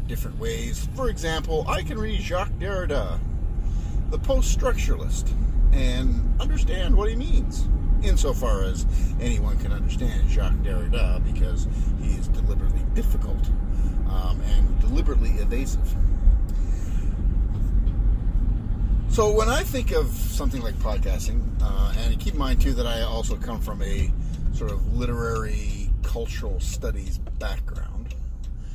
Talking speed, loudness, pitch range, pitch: 125 wpm, -26 LUFS, 75-100 Hz, 80 Hz